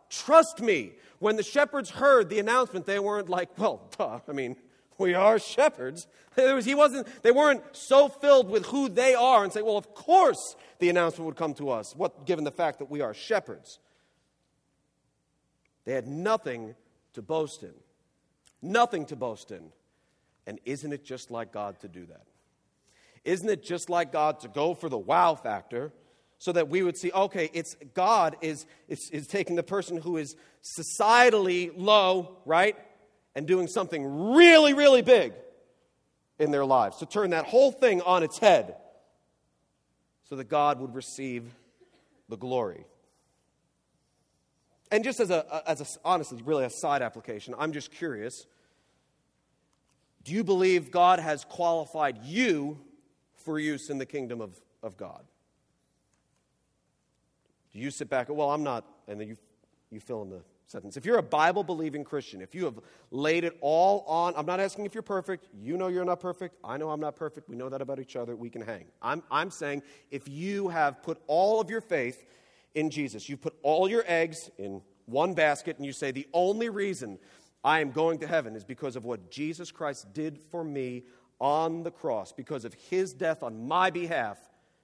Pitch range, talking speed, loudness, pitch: 140-195 Hz, 180 wpm, -27 LUFS, 160 Hz